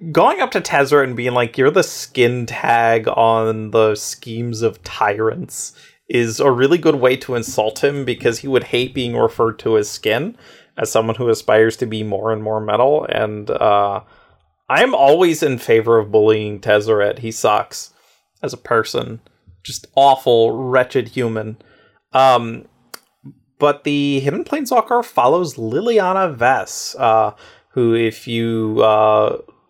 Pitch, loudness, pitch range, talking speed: 115 Hz, -16 LUFS, 110-135 Hz, 150 wpm